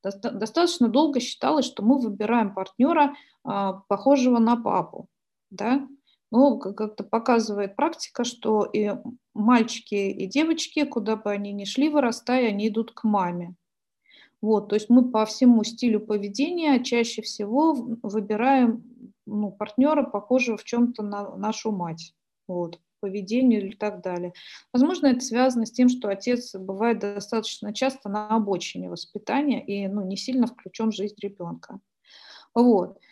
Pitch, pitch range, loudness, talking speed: 225 Hz, 205-250 Hz, -24 LUFS, 140 wpm